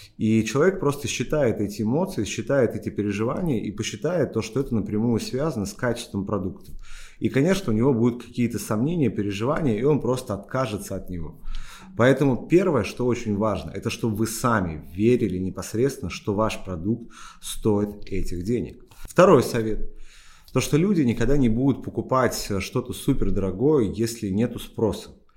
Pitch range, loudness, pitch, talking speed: 105-130 Hz, -24 LUFS, 110 Hz, 155 wpm